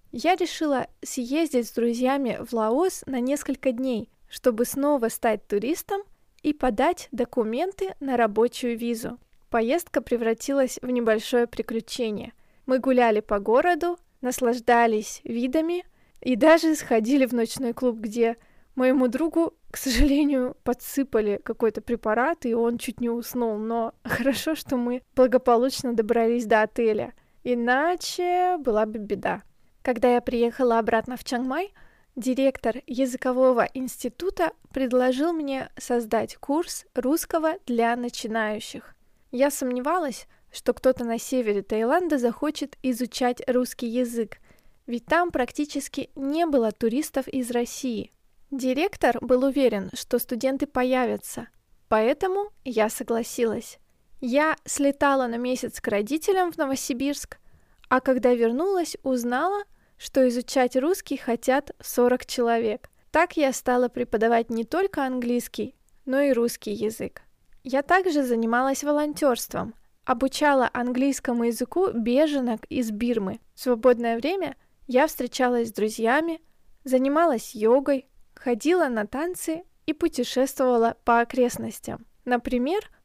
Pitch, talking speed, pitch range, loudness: 255 Hz, 115 wpm, 235-285 Hz, -25 LUFS